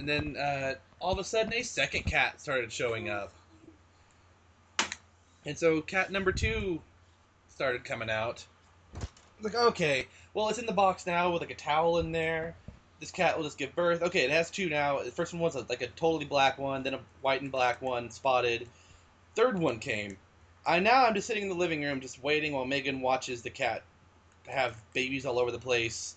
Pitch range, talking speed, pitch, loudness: 115-170 Hz, 205 wpm, 135 Hz, -30 LUFS